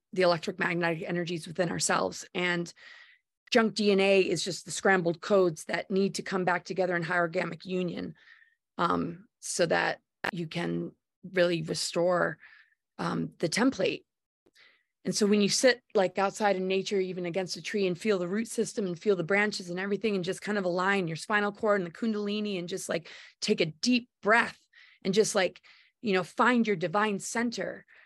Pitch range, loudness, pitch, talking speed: 175-210 Hz, -29 LUFS, 195 Hz, 180 wpm